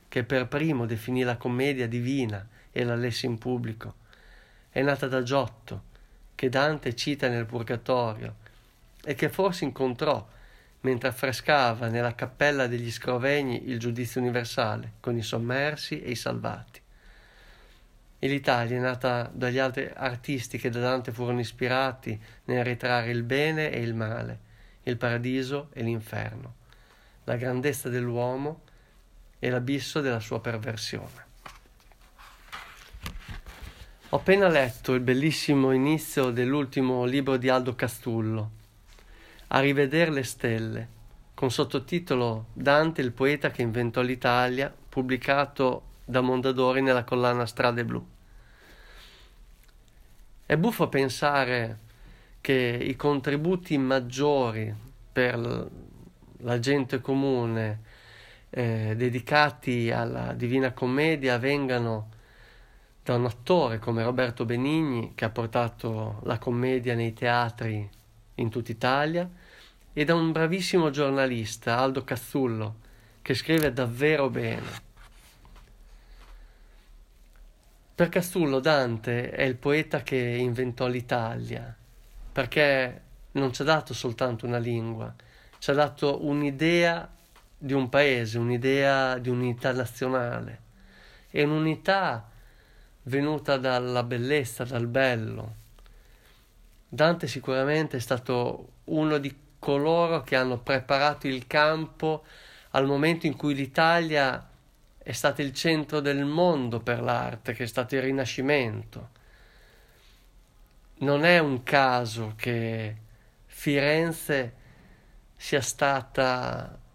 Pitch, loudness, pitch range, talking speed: 125 Hz, -27 LUFS, 120-140 Hz, 110 wpm